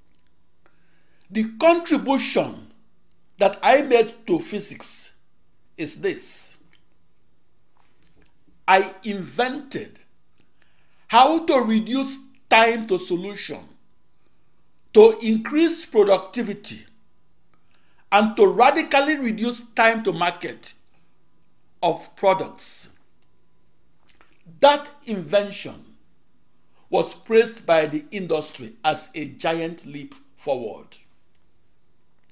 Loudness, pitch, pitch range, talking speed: -21 LUFS, 205 Hz, 160-245 Hz, 80 wpm